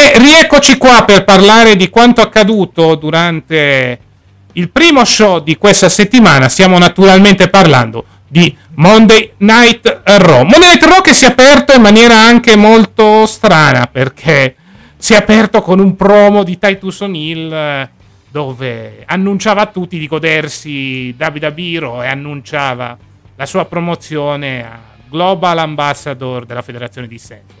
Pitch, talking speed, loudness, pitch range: 175 Hz, 140 wpm, -6 LUFS, 135-215 Hz